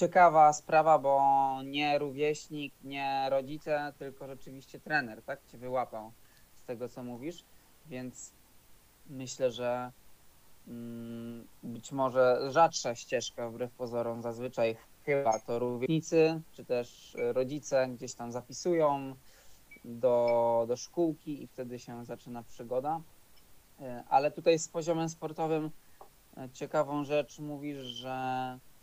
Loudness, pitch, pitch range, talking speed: -31 LUFS, 135 Hz, 120-150 Hz, 110 wpm